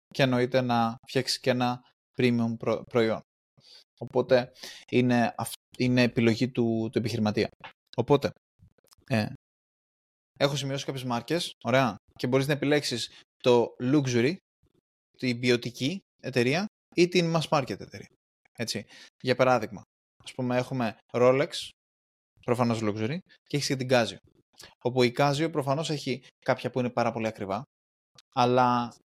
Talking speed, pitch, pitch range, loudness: 130 wpm, 125 Hz, 115-135 Hz, -27 LUFS